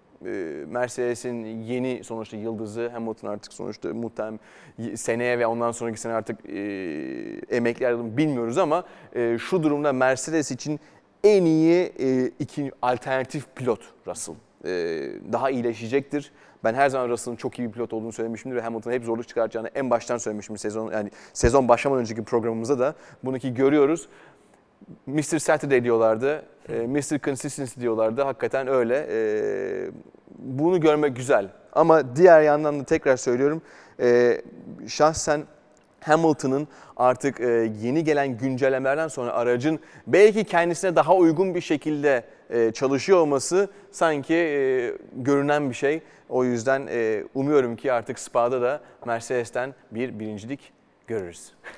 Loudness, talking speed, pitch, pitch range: -24 LUFS, 125 wpm, 130 Hz, 115-150 Hz